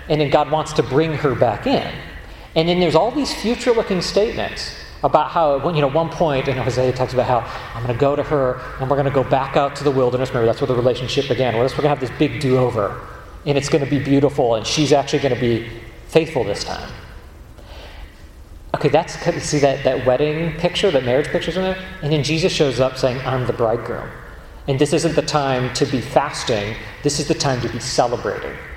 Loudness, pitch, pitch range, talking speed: -19 LUFS, 140 Hz, 125-155 Hz, 230 wpm